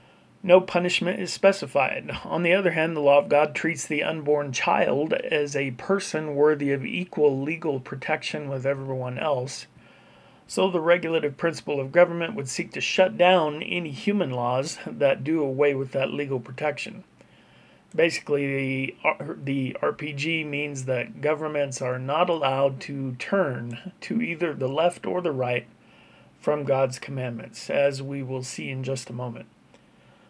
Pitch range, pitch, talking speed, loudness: 135-170 Hz, 145 Hz, 155 wpm, -25 LUFS